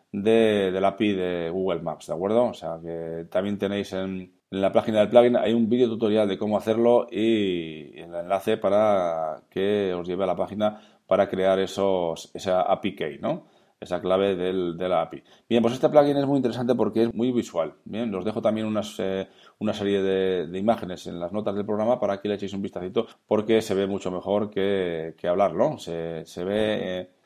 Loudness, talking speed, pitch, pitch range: -25 LUFS, 210 wpm, 100 Hz, 90-110 Hz